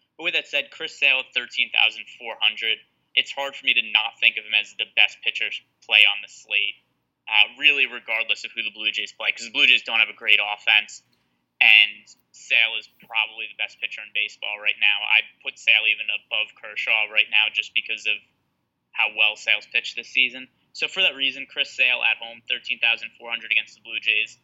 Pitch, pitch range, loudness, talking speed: 110 Hz, 105-120 Hz, -20 LUFS, 205 wpm